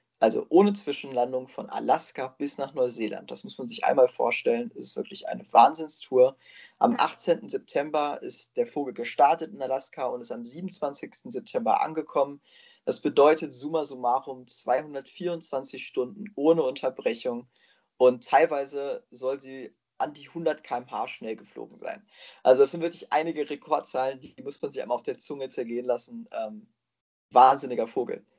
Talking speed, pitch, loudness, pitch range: 150 wpm, 145 Hz, -27 LUFS, 130-170 Hz